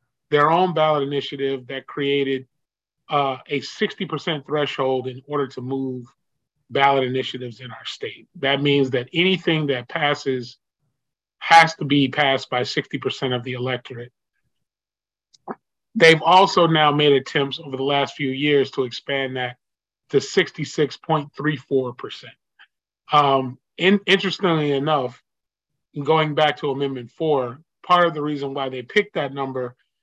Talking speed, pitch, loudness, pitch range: 135 wpm, 140 Hz, -20 LUFS, 130-155 Hz